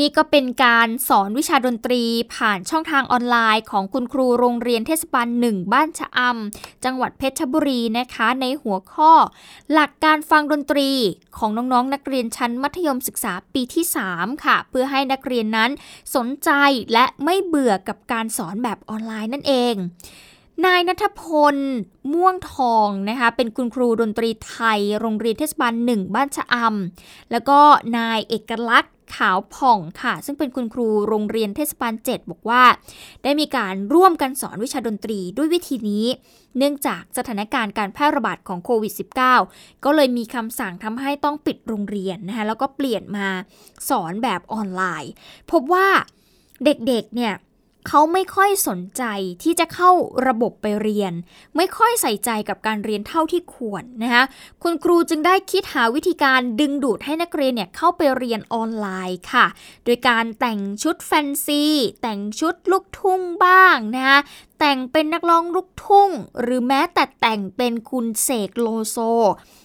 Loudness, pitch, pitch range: -19 LUFS, 250 Hz, 220-295 Hz